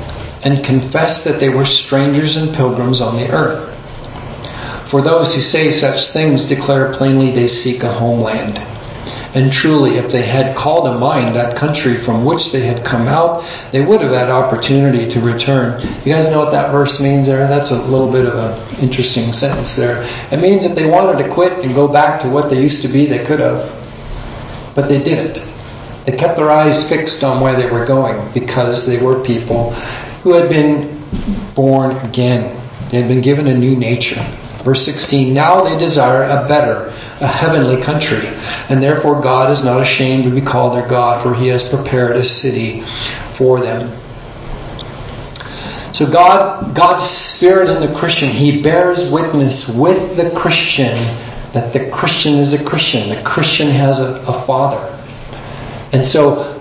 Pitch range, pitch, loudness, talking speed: 120-145 Hz, 135 Hz, -12 LUFS, 175 wpm